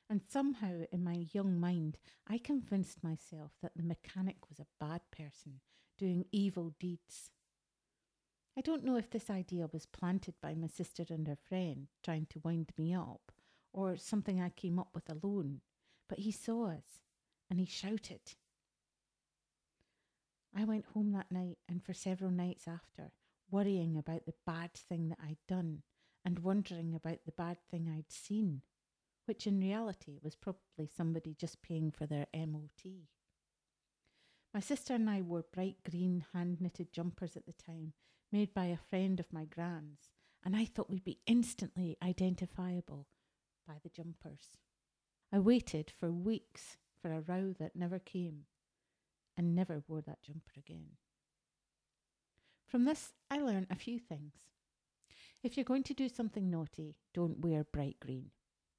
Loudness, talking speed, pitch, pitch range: -40 LUFS, 155 wpm, 175 Hz, 160-195 Hz